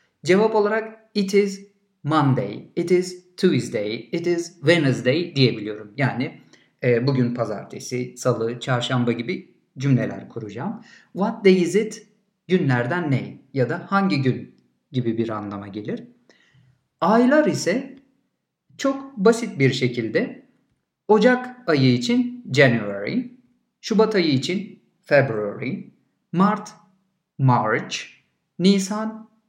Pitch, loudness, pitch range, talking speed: 175 Hz, -22 LUFS, 125-215 Hz, 105 wpm